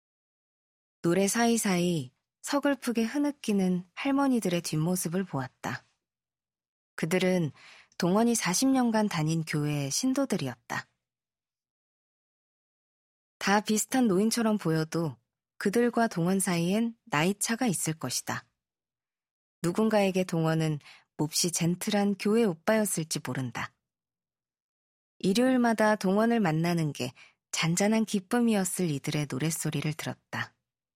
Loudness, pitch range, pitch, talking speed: -28 LUFS, 155-220 Hz, 180 Hz, 245 characters per minute